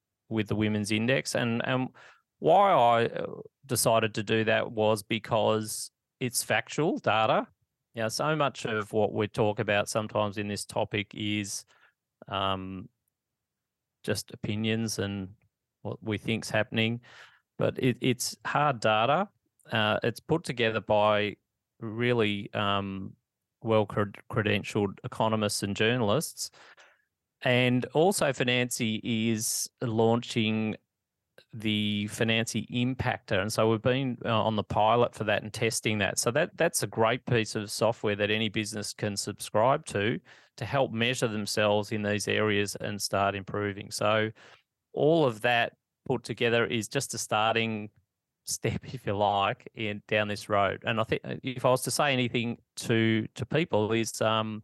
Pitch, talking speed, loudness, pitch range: 110 Hz, 145 wpm, -28 LUFS, 105-120 Hz